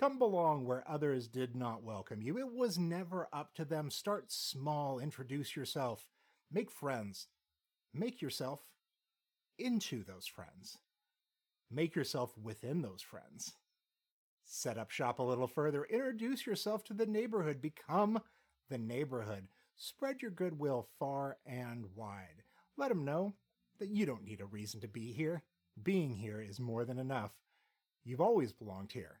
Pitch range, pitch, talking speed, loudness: 120-175 Hz, 140 Hz, 150 wpm, -40 LUFS